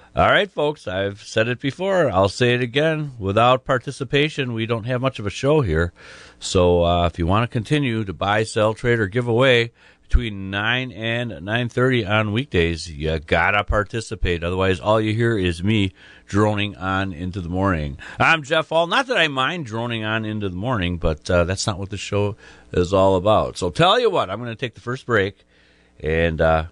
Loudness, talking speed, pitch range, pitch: -20 LUFS, 205 wpm, 95-125 Hz, 110 Hz